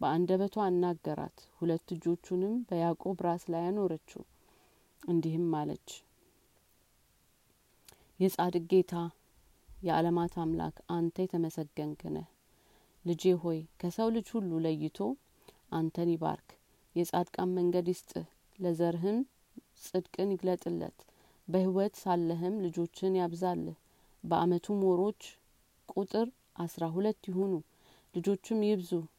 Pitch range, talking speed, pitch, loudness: 170-190 Hz, 90 wpm, 175 Hz, -33 LUFS